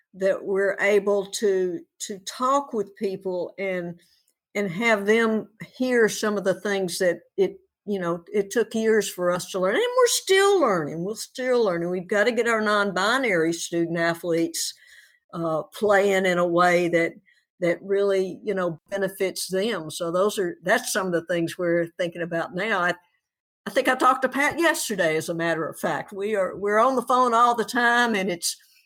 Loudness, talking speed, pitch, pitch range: -23 LUFS, 190 wpm, 195 Hz, 175-225 Hz